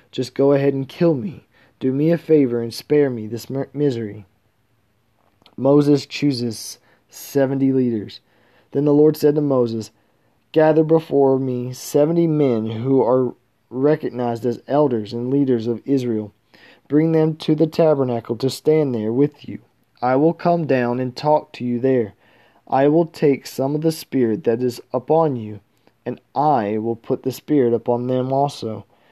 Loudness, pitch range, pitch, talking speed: -19 LUFS, 115-145 Hz, 130 Hz, 160 wpm